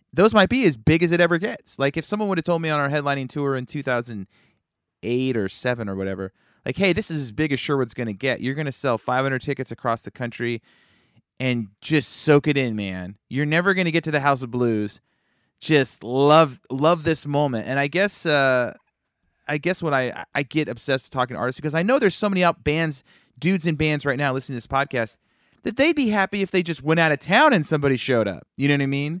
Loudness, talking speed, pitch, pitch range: -22 LUFS, 240 wpm, 140 Hz, 125-160 Hz